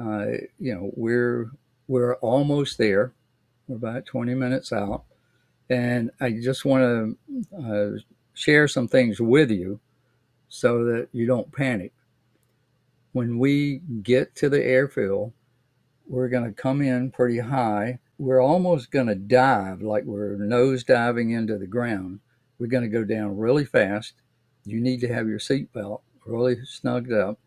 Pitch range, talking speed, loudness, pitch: 115-130 Hz, 150 wpm, -24 LUFS, 125 Hz